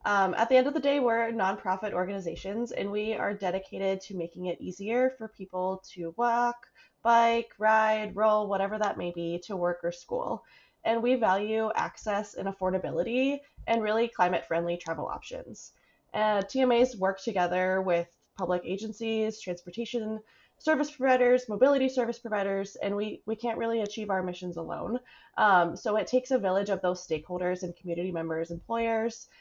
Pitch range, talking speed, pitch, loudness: 180-235 Hz, 165 wpm, 210 Hz, -29 LUFS